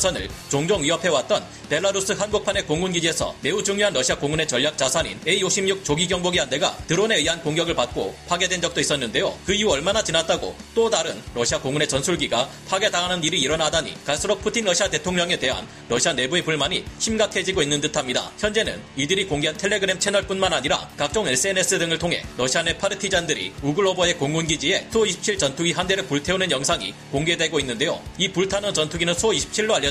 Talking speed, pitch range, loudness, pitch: 435 characters per minute, 150-195 Hz, -21 LUFS, 175 Hz